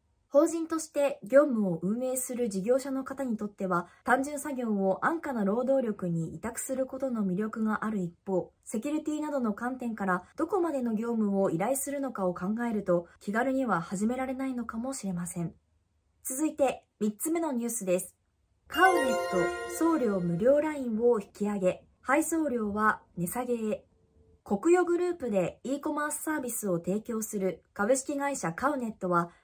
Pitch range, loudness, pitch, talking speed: 190-270 Hz, -30 LUFS, 235 Hz, 340 characters per minute